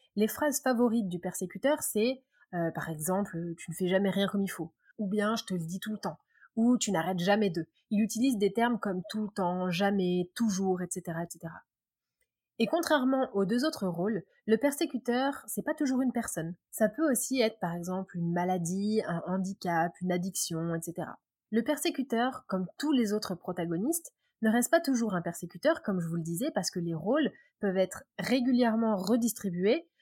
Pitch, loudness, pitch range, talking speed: 205 Hz, -31 LUFS, 180-240 Hz, 190 wpm